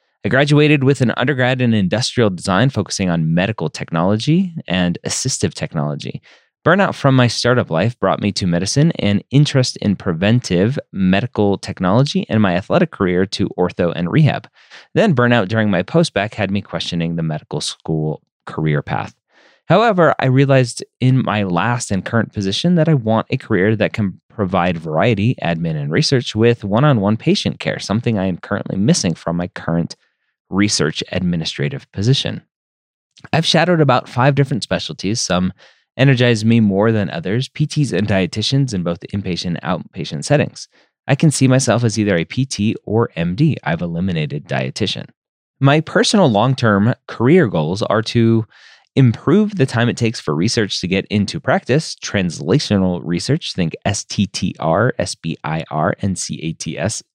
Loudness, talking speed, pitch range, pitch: -17 LUFS, 155 wpm, 95-135 Hz, 110 Hz